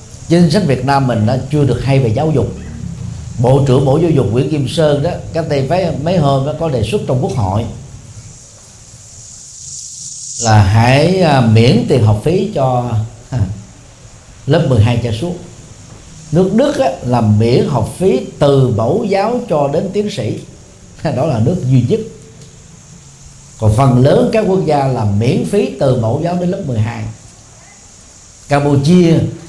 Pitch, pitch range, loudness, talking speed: 135 Hz, 115-155 Hz, -13 LUFS, 160 wpm